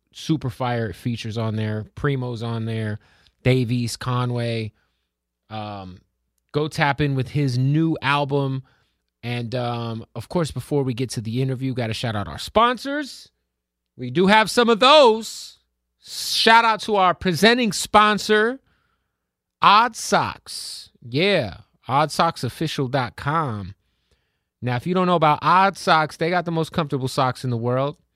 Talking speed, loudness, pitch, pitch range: 145 wpm, -20 LUFS, 130 Hz, 110-165 Hz